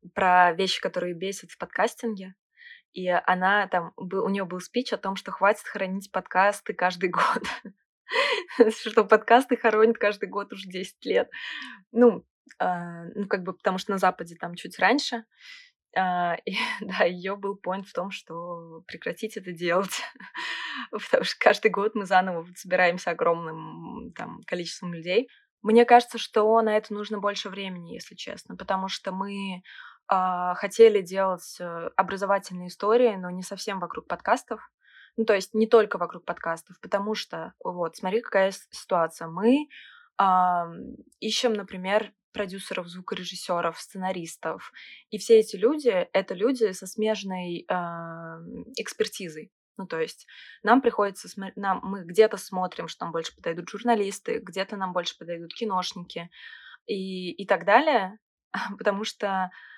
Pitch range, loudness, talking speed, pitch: 180-220 Hz, -26 LUFS, 145 wpm, 195 Hz